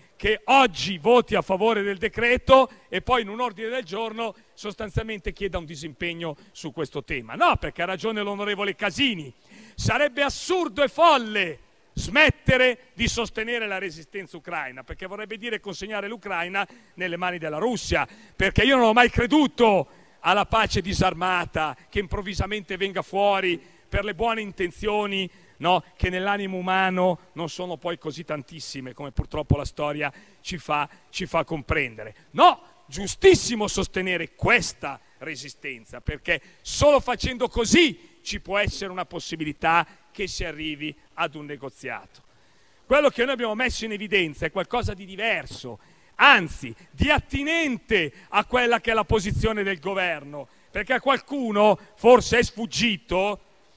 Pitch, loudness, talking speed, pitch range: 200 Hz, -23 LUFS, 145 wpm, 175-230 Hz